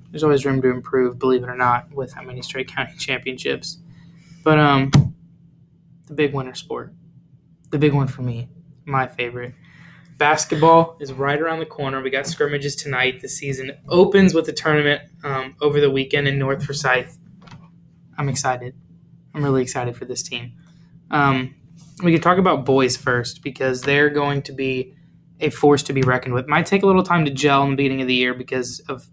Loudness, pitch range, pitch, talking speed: -19 LUFS, 130-160 Hz, 145 Hz, 190 wpm